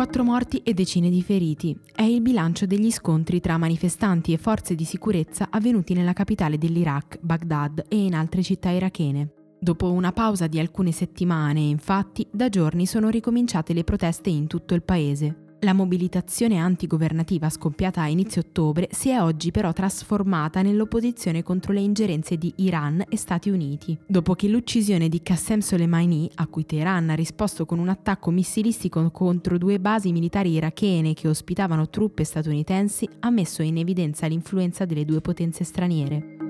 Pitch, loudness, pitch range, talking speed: 180 Hz, -23 LUFS, 165-200 Hz, 160 wpm